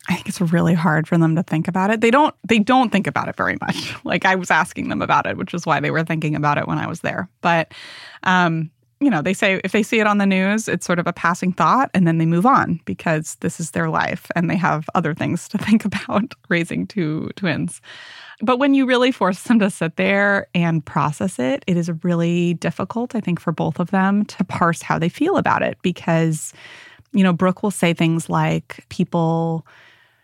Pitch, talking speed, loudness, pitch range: 175 Hz, 230 wpm, -19 LUFS, 165-200 Hz